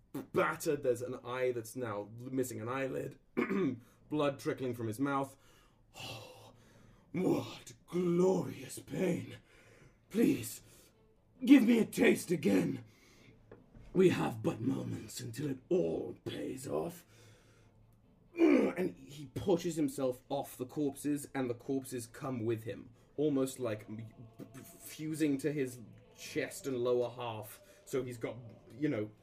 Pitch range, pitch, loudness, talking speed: 115-145 Hz, 130 Hz, -35 LUFS, 125 wpm